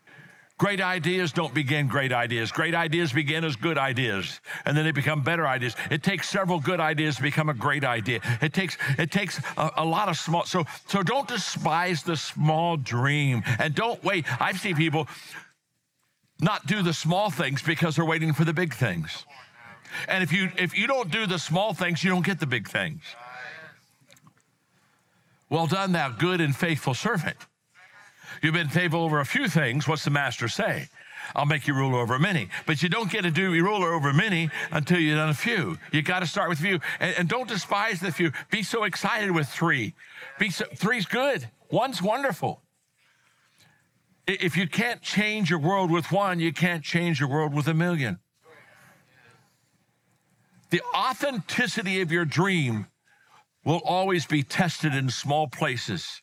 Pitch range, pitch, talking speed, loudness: 150-185 Hz, 165 Hz, 175 wpm, -25 LUFS